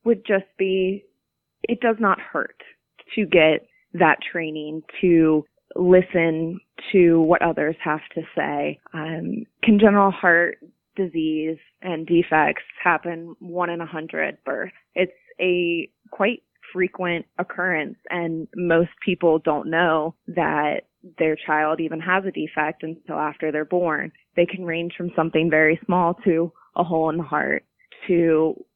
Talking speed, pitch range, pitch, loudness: 140 wpm, 160-185 Hz, 170 Hz, -22 LUFS